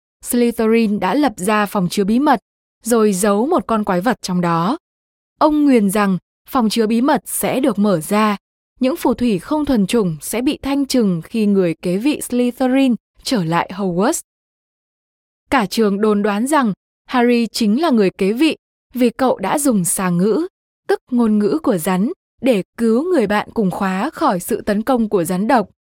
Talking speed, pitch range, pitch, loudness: 185 wpm, 200-260 Hz, 225 Hz, -17 LUFS